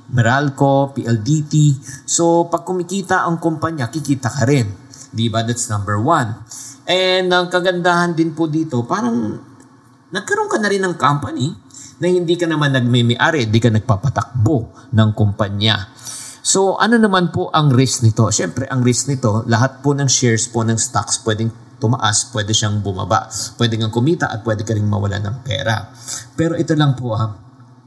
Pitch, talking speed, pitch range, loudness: 130 Hz, 160 wpm, 115-155 Hz, -17 LUFS